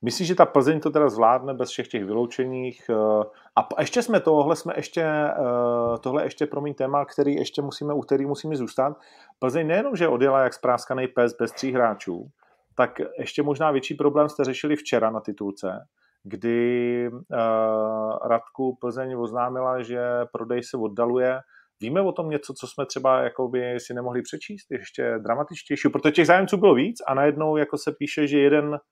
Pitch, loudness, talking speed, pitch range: 130 Hz, -24 LUFS, 170 wpm, 120-150 Hz